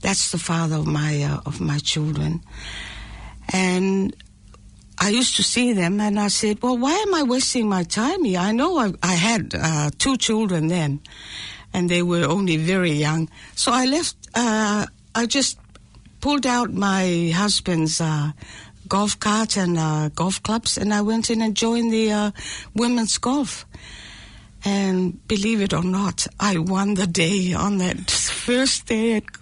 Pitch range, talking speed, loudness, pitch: 155-220 Hz, 170 wpm, -21 LUFS, 190 Hz